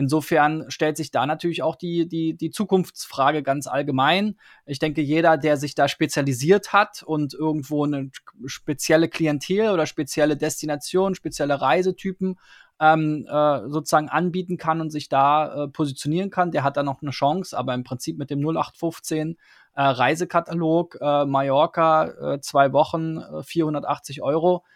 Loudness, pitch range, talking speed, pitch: -22 LUFS, 145-165 Hz, 150 wpm, 155 Hz